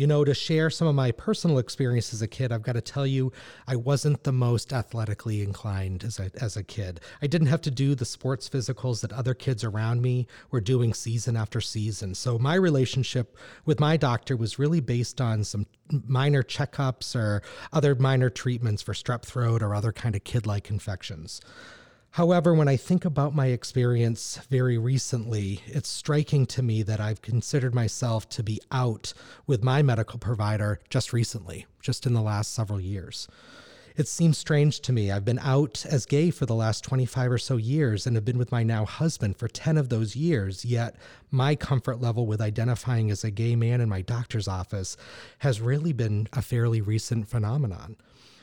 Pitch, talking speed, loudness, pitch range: 120 Hz, 190 wpm, -27 LUFS, 110-135 Hz